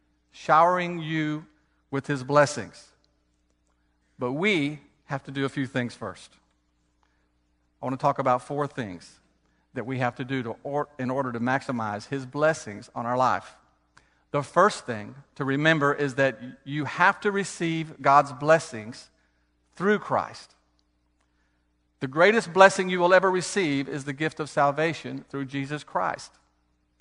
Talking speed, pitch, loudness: 150 wpm, 135 Hz, -25 LUFS